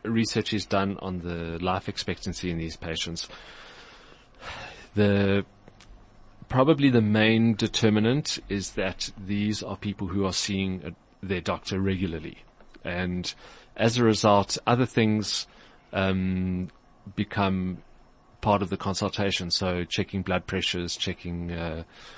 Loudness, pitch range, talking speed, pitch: -27 LUFS, 90-105 Hz, 120 wpm, 100 Hz